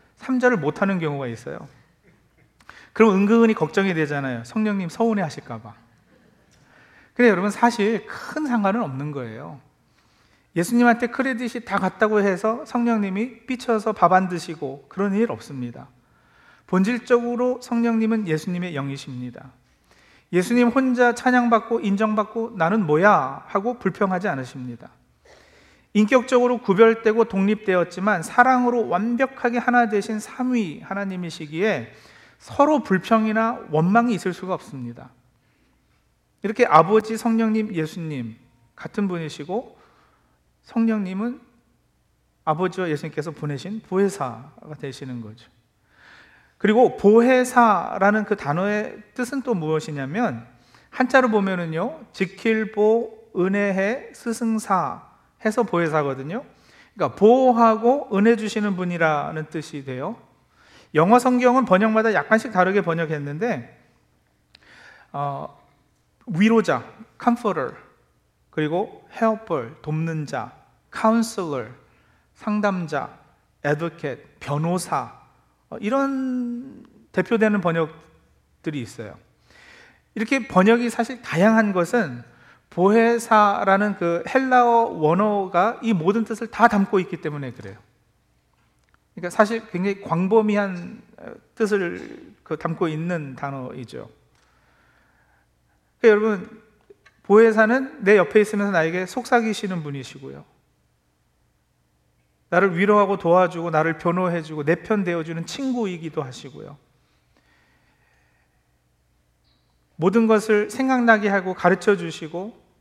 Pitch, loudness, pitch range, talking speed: 195 Hz, -21 LUFS, 155-225 Hz, 275 characters per minute